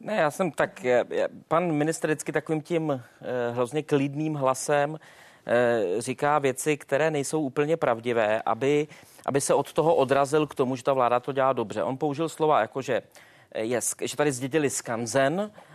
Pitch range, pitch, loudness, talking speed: 130-155 Hz, 145 Hz, -26 LUFS, 160 wpm